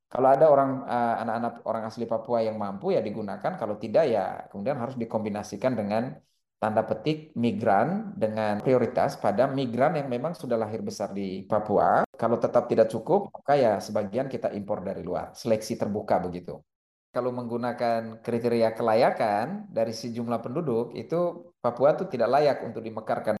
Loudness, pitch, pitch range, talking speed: -27 LUFS, 120 Hz, 110-130 Hz, 155 wpm